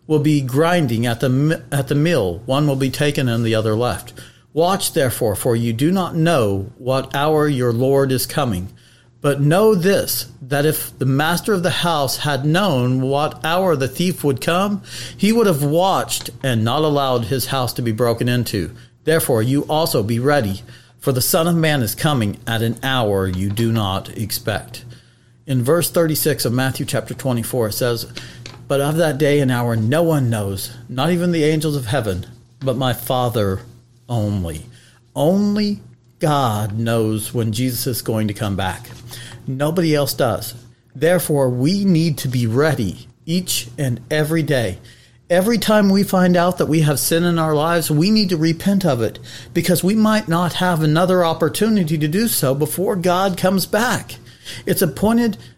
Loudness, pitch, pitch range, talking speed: -18 LUFS, 135 Hz, 120-165 Hz, 175 wpm